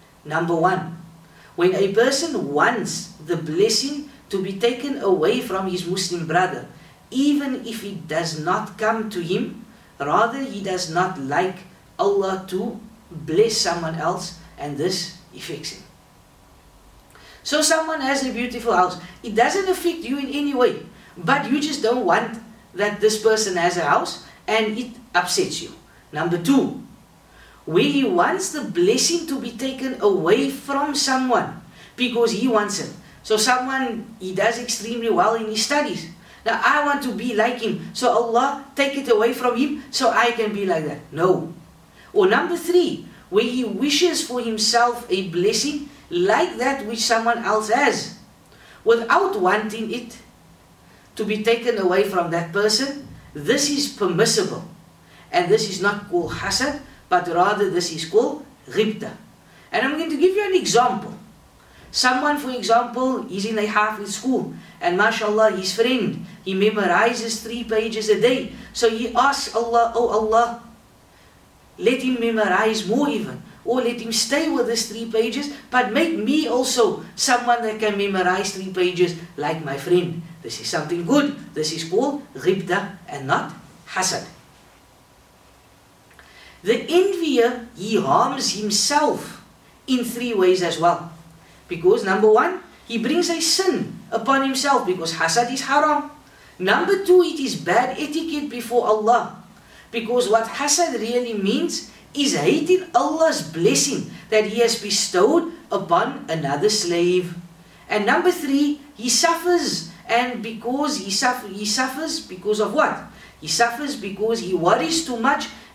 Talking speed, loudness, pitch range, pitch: 150 wpm, -21 LUFS, 195-270 Hz, 230 Hz